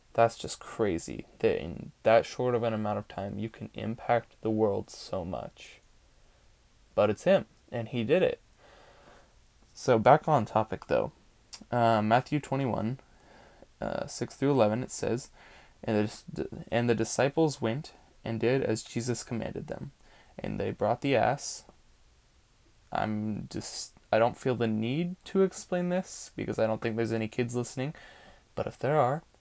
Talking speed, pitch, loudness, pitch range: 160 wpm, 115 Hz, -30 LUFS, 110-140 Hz